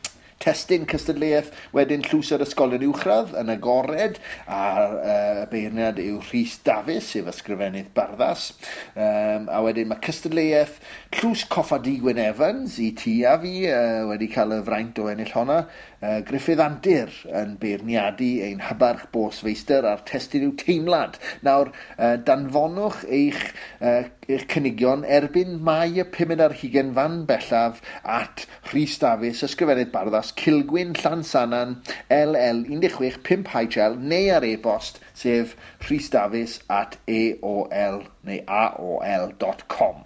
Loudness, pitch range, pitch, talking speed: -23 LUFS, 115-160 Hz, 135 Hz, 125 wpm